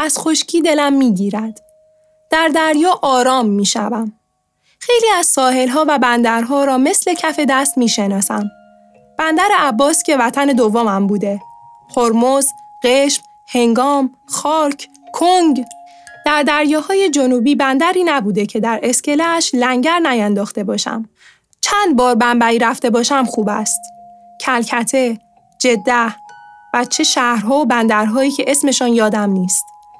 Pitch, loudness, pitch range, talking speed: 265 Hz, -14 LUFS, 230-310 Hz, 120 wpm